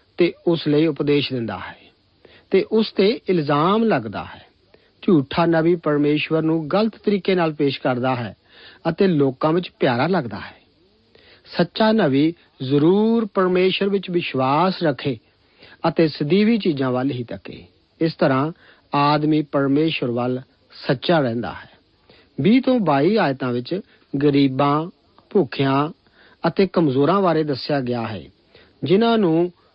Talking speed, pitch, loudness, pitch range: 130 wpm, 155 Hz, -20 LUFS, 135-180 Hz